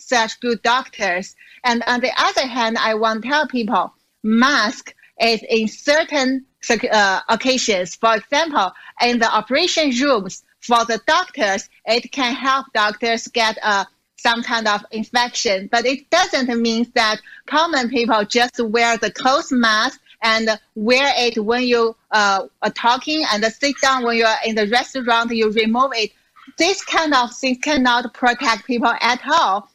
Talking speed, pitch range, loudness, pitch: 160 wpm, 225-260 Hz, -18 LUFS, 235 Hz